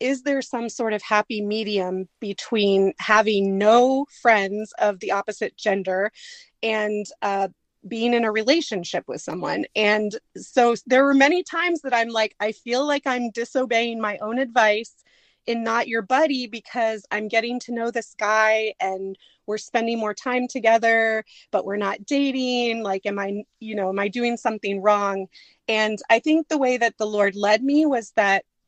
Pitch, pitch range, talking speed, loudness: 220 Hz, 210-245 Hz, 175 wpm, -22 LUFS